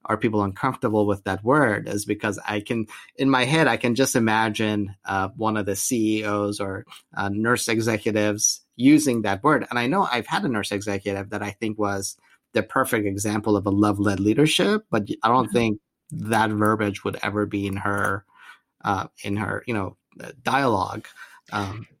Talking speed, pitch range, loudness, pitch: 180 wpm, 100-115 Hz, -23 LUFS, 105 Hz